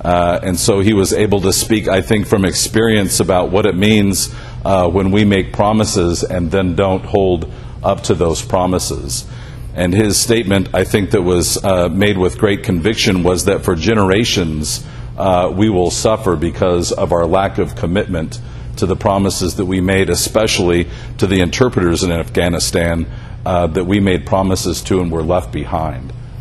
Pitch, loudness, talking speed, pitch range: 95 Hz, -14 LUFS, 175 wpm, 90-110 Hz